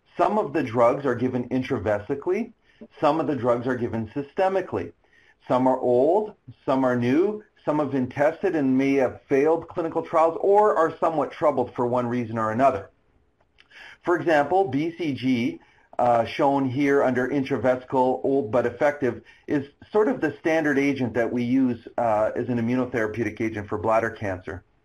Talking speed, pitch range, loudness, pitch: 160 wpm, 120-160 Hz, -24 LUFS, 130 Hz